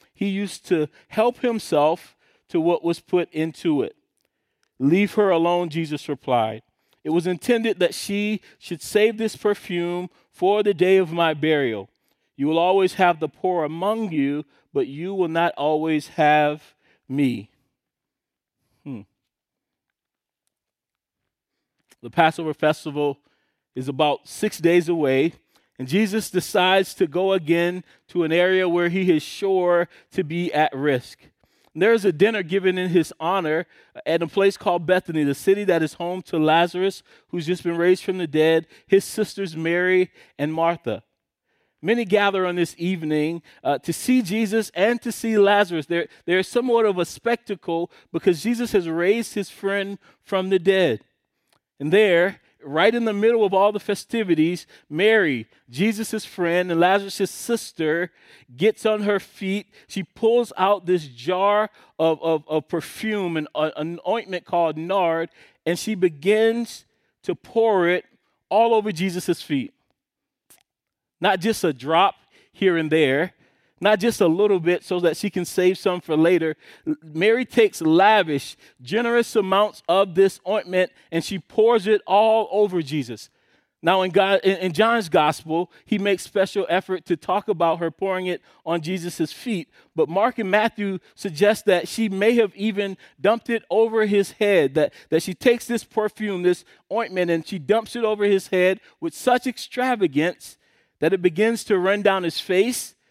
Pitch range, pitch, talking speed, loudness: 165-210 Hz, 185 Hz, 160 wpm, -22 LUFS